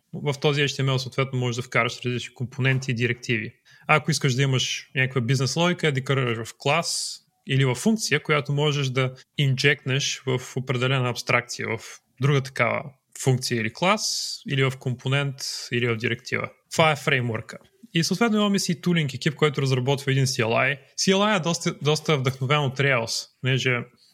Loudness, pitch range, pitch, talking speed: -24 LUFS, 125-150 Hz, 135 Hz, 160 wpm